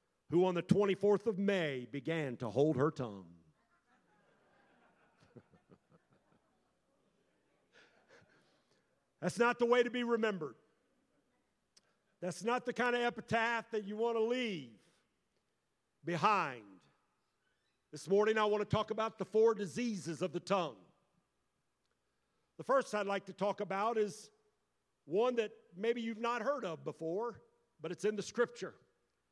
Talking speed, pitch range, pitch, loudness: 130 wpm, 165-230 Hz, 205 Hz, -35 LUFS